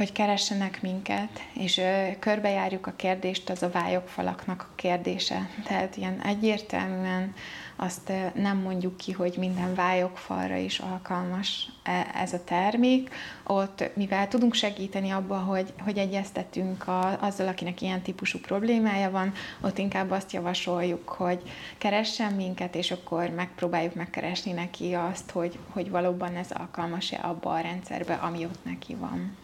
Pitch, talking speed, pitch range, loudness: 185 Hz, 135 wpm, 180-195 Hz, -29 LUFS